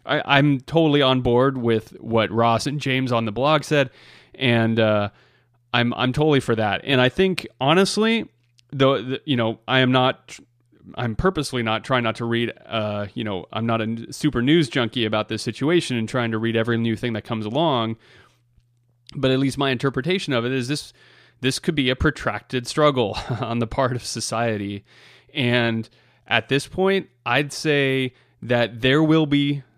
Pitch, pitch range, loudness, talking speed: 125 Hz, 115-140 Hz, -21 LUFS, 180 wpm